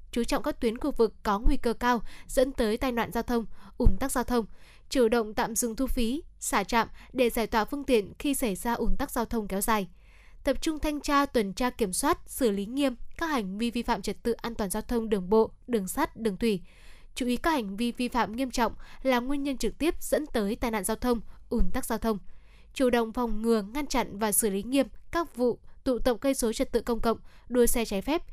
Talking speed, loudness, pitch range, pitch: 250 wpm, -29 LUFS, 225-265 Hz, 235 Hz